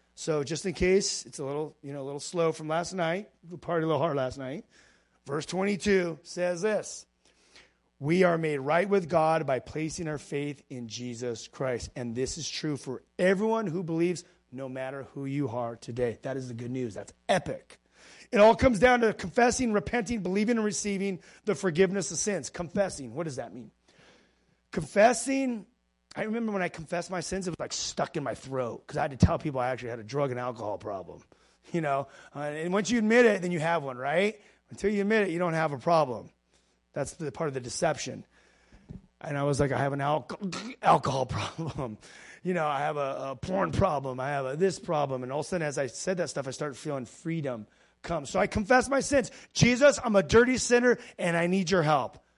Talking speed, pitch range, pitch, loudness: 215 wpm, 135-195 Hz, 165 Hz, -29 LUFS